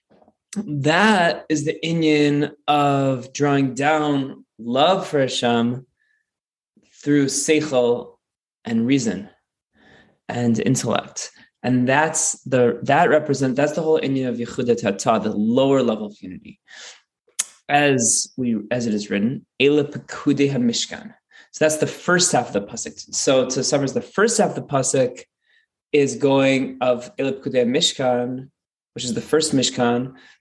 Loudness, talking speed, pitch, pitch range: -20 LUFS, 130 wpm, 140 Hz, 125-150 Hz